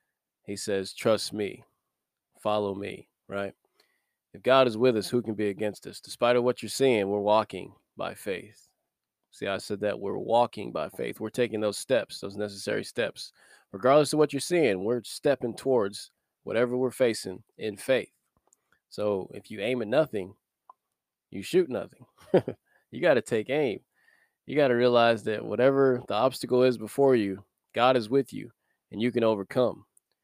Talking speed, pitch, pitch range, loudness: 175 wpm, 115 Hz, 105-125 Hz, -27 LUFS